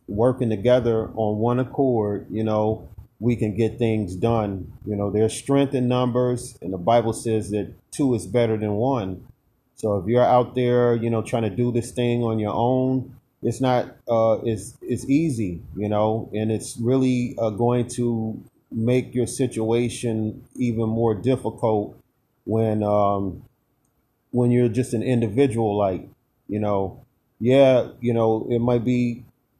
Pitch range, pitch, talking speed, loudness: 110-125 Hz, 115 Hz, 160 wpm, -22 LUFS